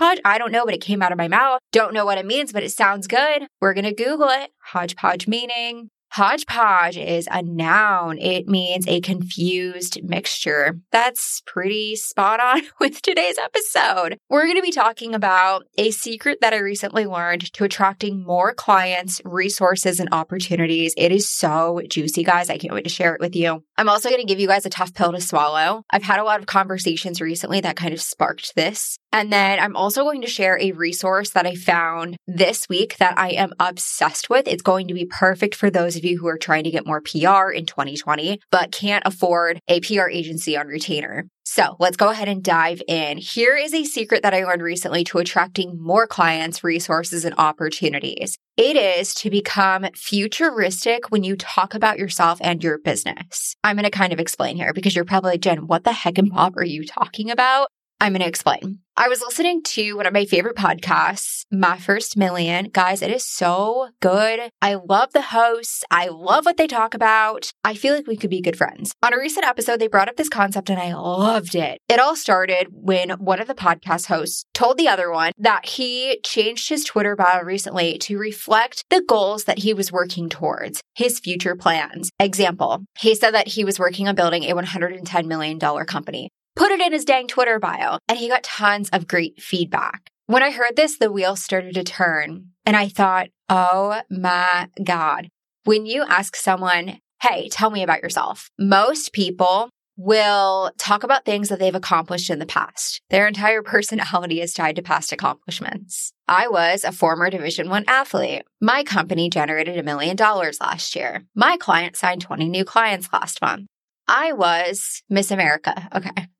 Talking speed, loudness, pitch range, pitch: 195 wpm, -19 LUFS, 175-220 Hz, 190 Hz